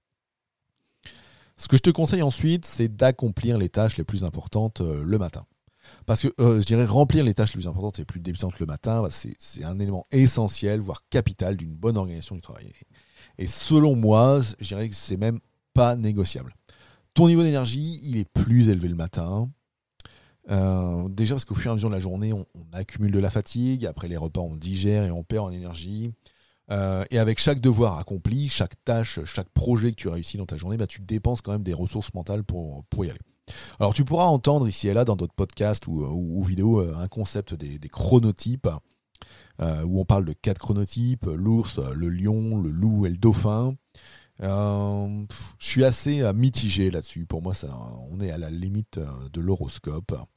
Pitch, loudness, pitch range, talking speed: 105 Hz, -24 LUFS, 90-115 Hz, 205 wpm